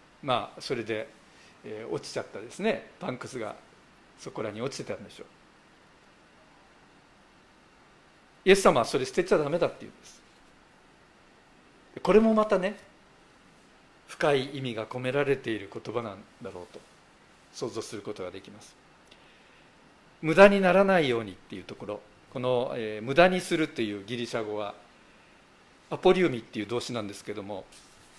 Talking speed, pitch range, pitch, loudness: 310 characters per minute, 110-185 Hz, 130 Hz, -27 LUFS